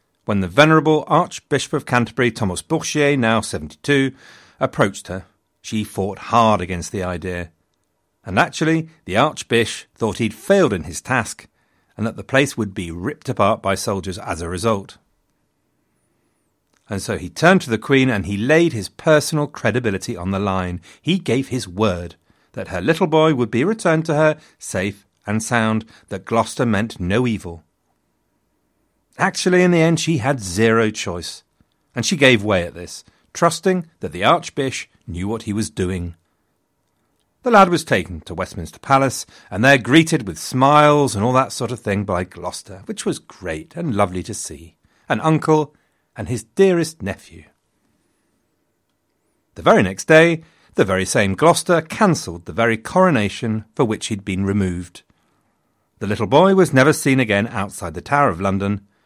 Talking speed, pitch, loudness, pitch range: 165 wpm, 115 Hz, -18 LUFS, 95-150 Hz